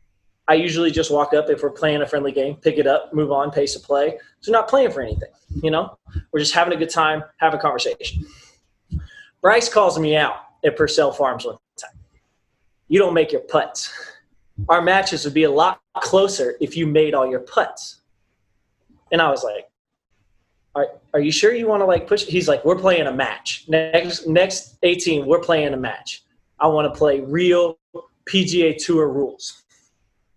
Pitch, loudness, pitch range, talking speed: 160 Hz, -19 LUFS, 145-180 Hz, 190 wpm